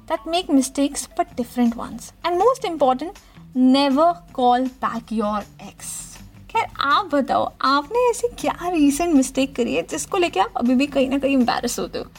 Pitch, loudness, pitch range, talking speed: 275 Hz, -20 LUFS, 250-340 Hz, 175 wpm